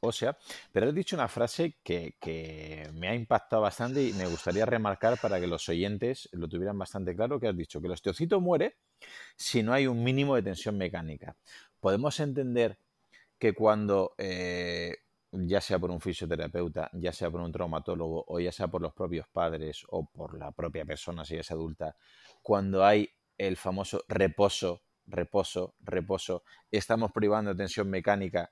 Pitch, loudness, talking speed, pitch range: 95 Hz, -31 LUFS, 175 wpm, 85-110 Hz